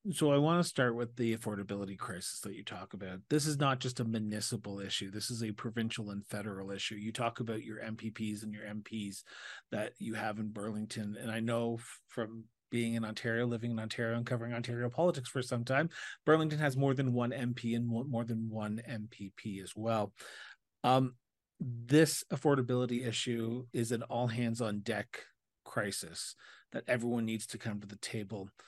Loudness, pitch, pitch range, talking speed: -36 LUFS, 115 Hz, 105-125 Hz, 185 wpm